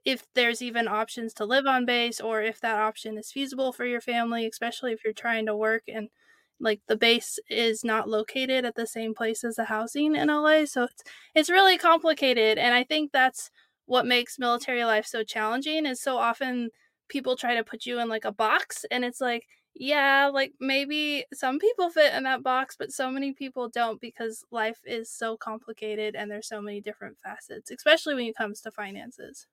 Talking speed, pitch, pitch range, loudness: 205 wpm, 240 Hz, 225-270 Hz, -26 LUFS